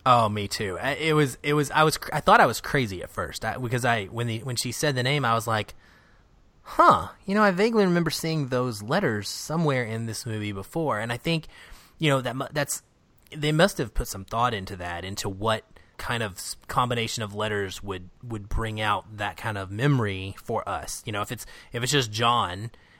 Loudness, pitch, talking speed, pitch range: -25 LUFS, 120 Hz, 215 wpm, 105-145 Hz